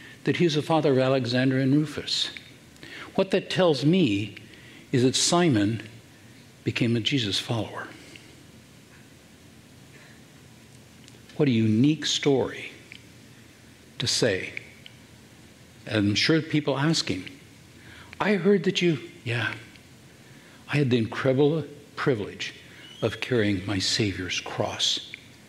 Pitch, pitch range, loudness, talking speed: 130 Hz, 110-145 Hz, -25 LUFS, 105 wpm